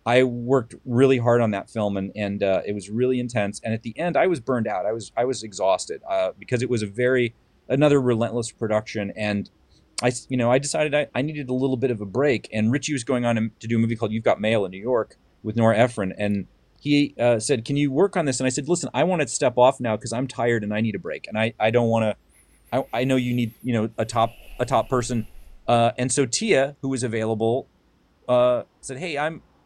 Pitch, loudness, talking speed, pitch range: 120 Hz, -23 LUFS, 255 wpm, 110-130 Hz